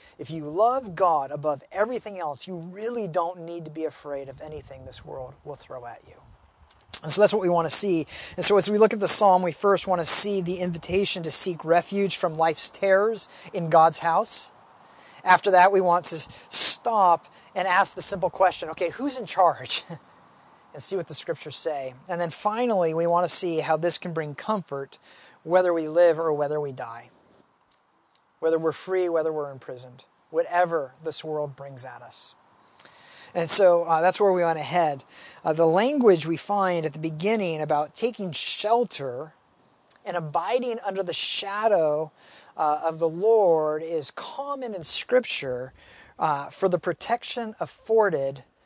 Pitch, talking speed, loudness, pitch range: 175 Hz, 175 wpm, -24 LUFS, 155-195 Hz